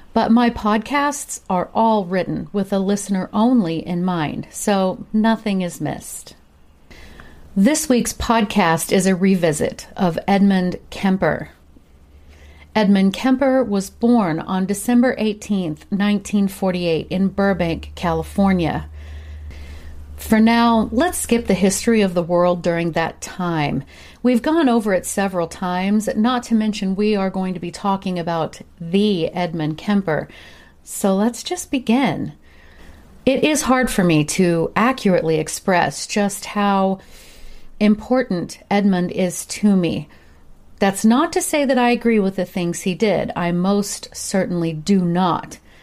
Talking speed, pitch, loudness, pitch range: 135 wpm, 195 Hz, -19 LUFS, 170-220 Hz